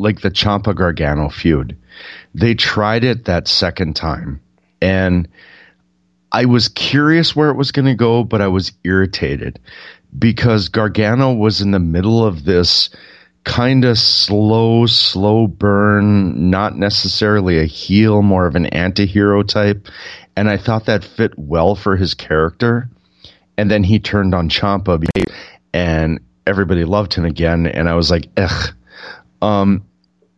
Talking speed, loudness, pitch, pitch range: 145 wpm, -14 LUFS, 100 Hz, 85-110 Hz